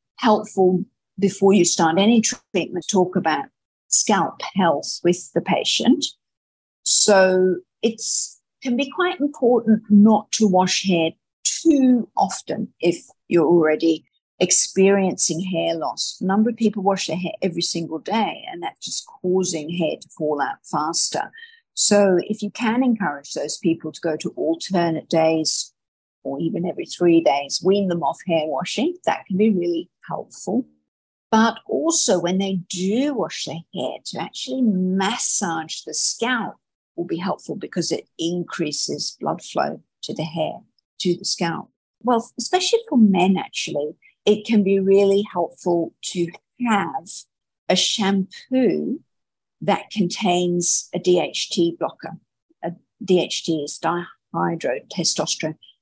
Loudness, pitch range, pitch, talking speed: -20 LUFS, 170-215 Hz, 185 Hz, 135 wpm